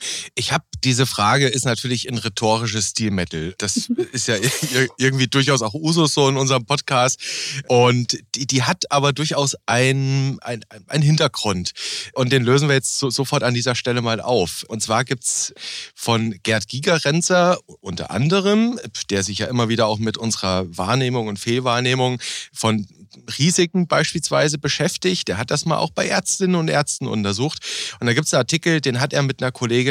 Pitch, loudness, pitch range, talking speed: 130 Hz, -19 LUFS, 115-145 Hz, 175 wpm